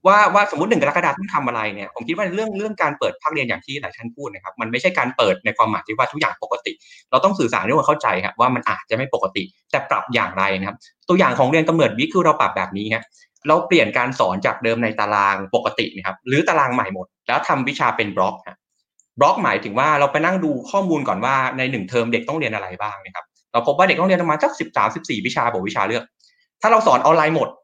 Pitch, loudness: 150 Hz, -19 LUFS